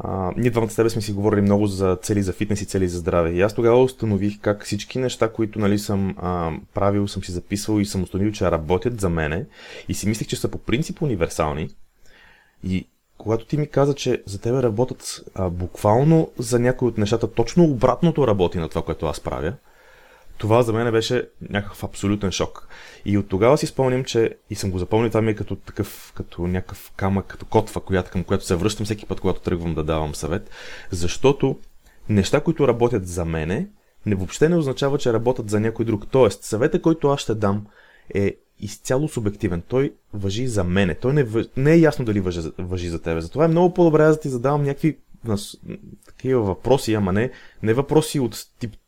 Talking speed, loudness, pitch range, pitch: 200 wpm, -22 LUFS, 95-125 Hz, 105 Hz